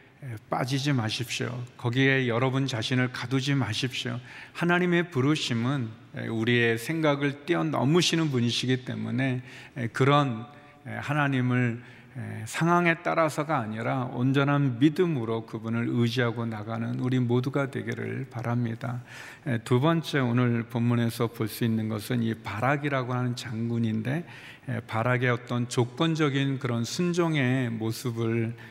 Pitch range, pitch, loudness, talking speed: 120-140 Hz, 125 Hz, -27 LUFS, 290 characters per minute